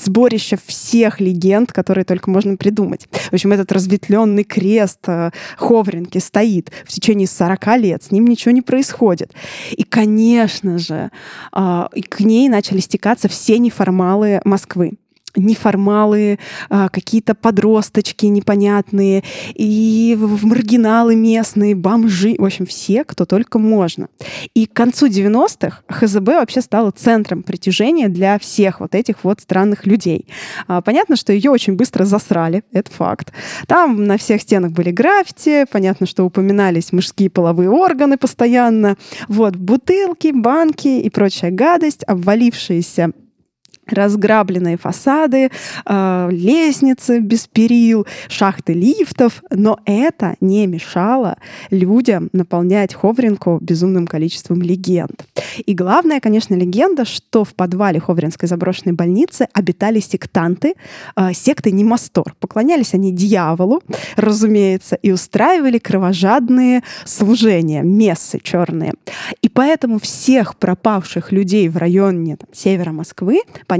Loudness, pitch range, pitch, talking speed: -14 LUFS, 185-230 Hz, 205 Hz, 120 wpm